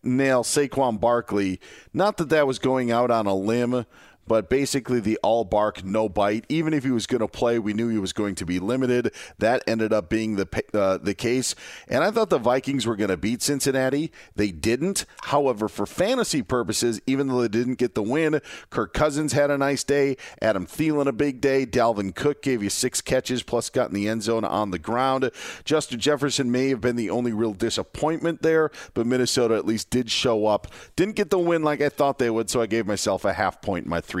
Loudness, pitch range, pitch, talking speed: -24 LUFS, 110-140 Hz, 125 Hz, 225 wpm